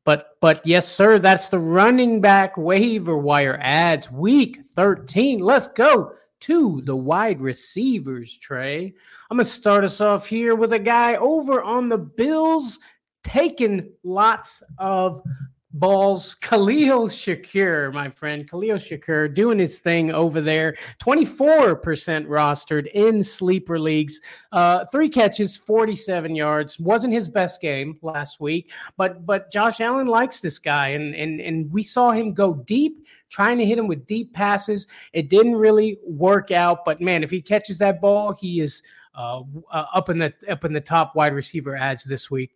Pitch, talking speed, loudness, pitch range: 185 Hz, 160 wpm, -20 LUFS, 155-220 Hz